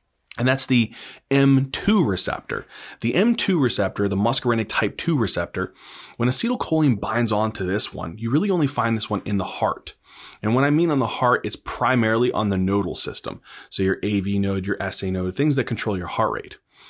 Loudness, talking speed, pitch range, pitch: -22 LUFS, 195 wpm, 100-135 Hz, 115 Hz